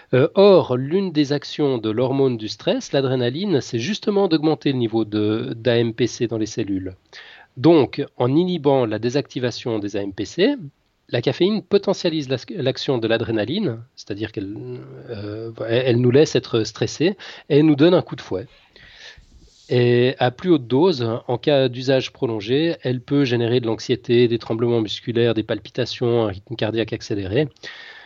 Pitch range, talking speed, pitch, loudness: 115-145 Hz, 150 wpm, 125 Hz, -20 LUFS